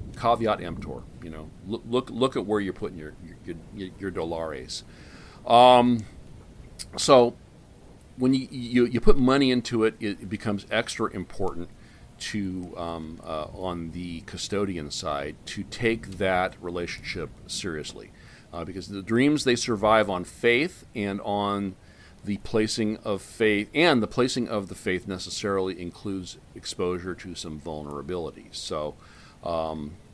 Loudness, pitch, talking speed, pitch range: -26 LUFS, 100 Hz, 140 wpm, 90-115 Hz